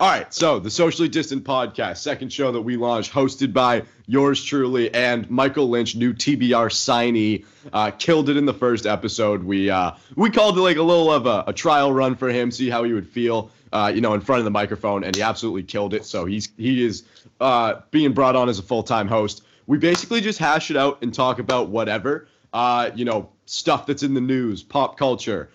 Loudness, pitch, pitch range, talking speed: -20 LUFS, 125 Hz, 110-140 Hz, 225 wpm